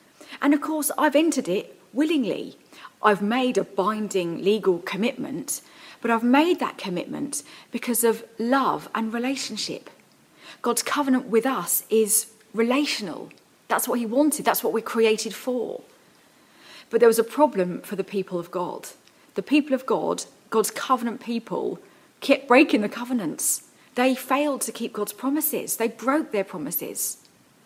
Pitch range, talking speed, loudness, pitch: 220-275 Hz, 150 wpm, -24 LUFS, 240 Hz